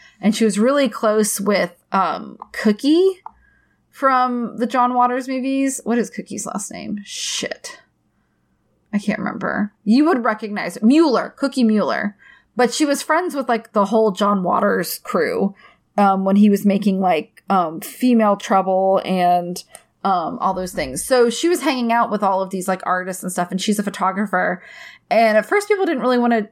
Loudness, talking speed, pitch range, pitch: -19 LUFS, 180 wpm, 200-255 Hz, 220 Hz